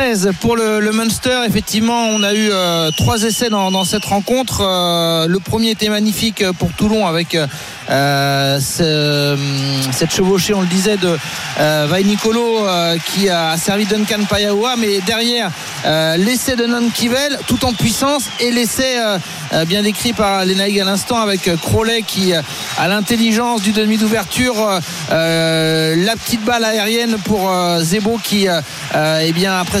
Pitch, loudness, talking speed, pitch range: 200 Hz, -15 LUFS, 160 wpm, 170-225 Hz